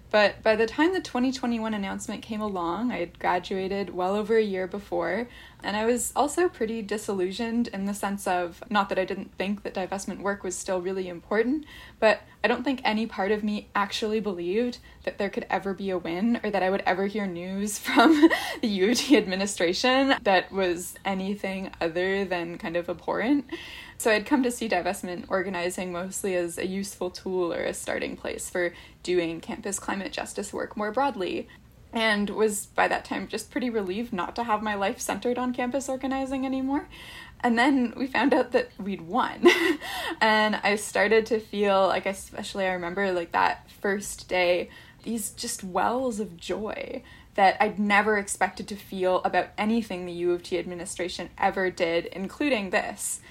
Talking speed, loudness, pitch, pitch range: 180 wpm, -27 LUFS, 205 Hz, 185-235 Hz